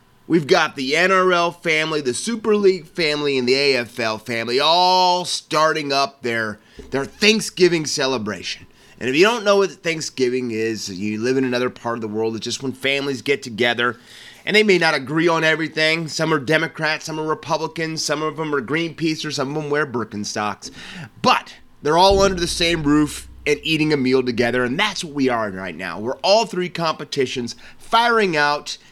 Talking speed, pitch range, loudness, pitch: 190 wpm, 125-170 Hz, -19 LUFS, 150 Hz